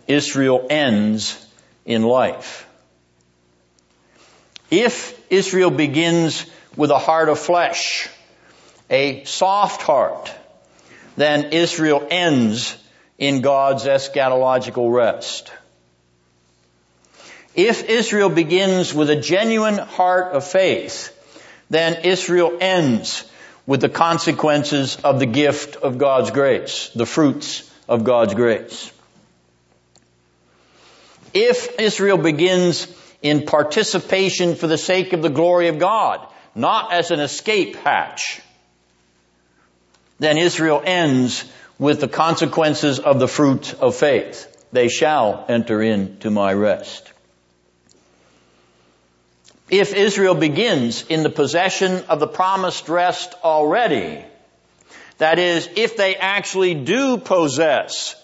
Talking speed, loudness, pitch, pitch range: 105 wpm, -18 LUFS, 150 Hz, 115-180 Hz